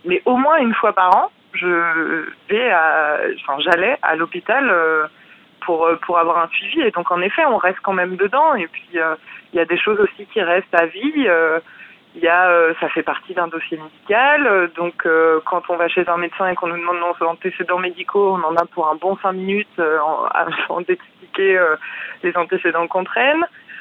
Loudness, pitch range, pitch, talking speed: -17 LUFS, 170-200 Hz, 180 Hz, 195 wpm